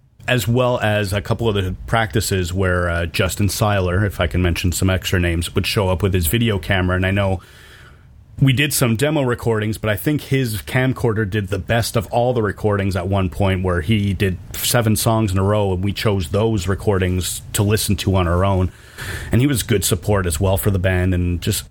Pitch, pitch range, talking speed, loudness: 105 Hz, 95-115 Hz, 220 wpm, -19 LUFS